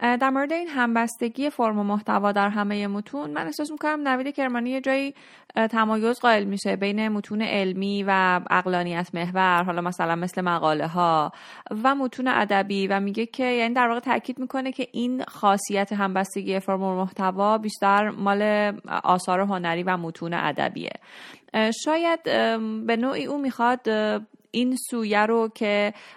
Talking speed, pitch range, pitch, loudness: 150 wpm, 195-250 Hz, 215 Hz, -24 LUFS